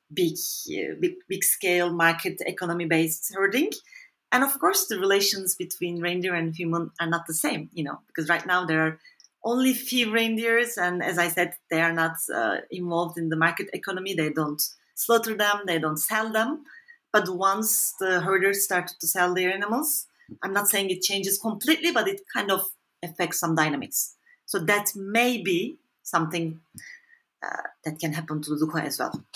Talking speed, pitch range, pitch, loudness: 180 wpm, 170-225 Hz, 185 Hz, -25 LUFS